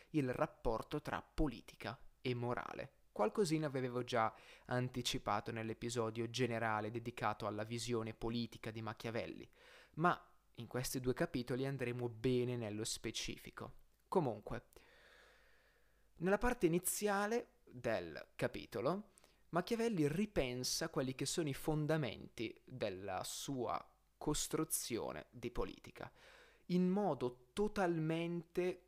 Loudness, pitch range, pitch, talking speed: -41 LUFS, 115-170 Hz, 130 Hz, 100 wpm